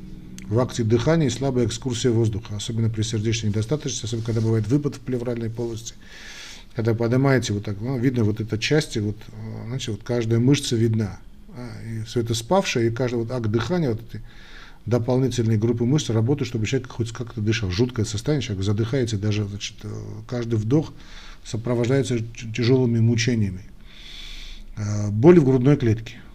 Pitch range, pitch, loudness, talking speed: 110-125 Hz, 115 Hz, -23 LUFS, 155 wpm